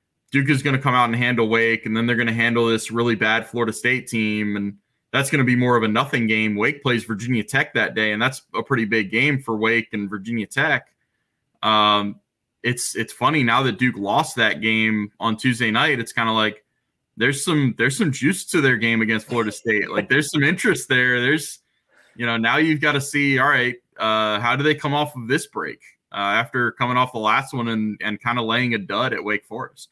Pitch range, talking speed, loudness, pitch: 110-130 Hz, 235 wpm, -20 LUFS, 115 Hz